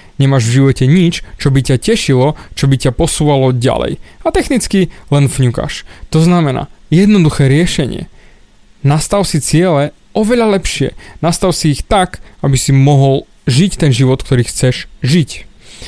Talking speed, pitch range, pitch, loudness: 145 wpm, 135-175 Hz, 145 Hz, -12 LUFS